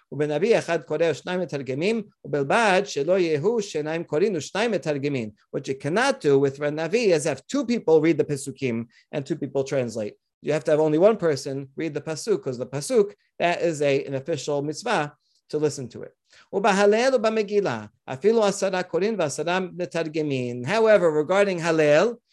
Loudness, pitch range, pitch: -23 LUFS, 145-200 Hz, 160 Hz